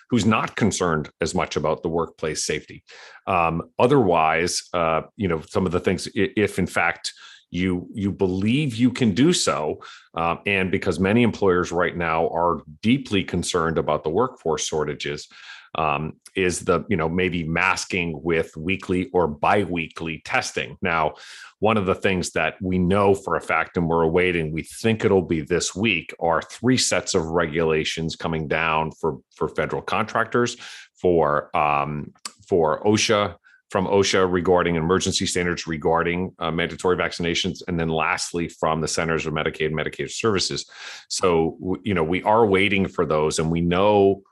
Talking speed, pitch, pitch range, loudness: 160 wpm, 90 Hz, 80-95 Hz, -22 LUFS